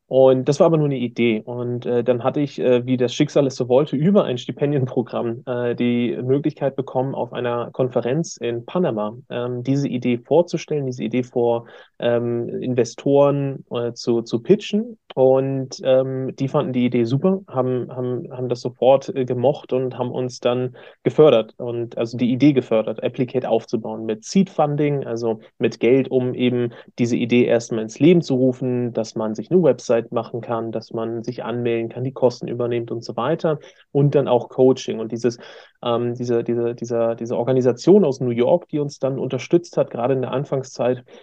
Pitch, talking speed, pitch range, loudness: 125 Hz, 185 wpm, 120-135 Hz, -20 LUFS